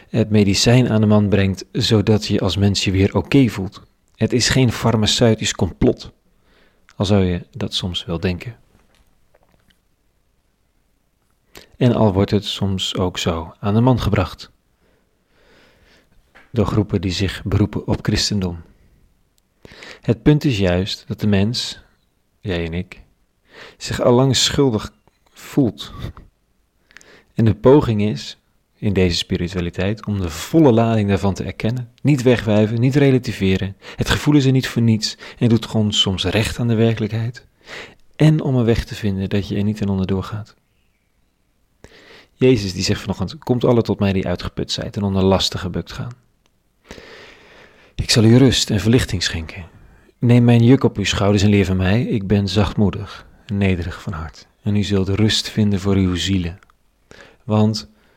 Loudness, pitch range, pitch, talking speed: -18 LUFS, 95-115 Hz, 105 Hz, 160 wpm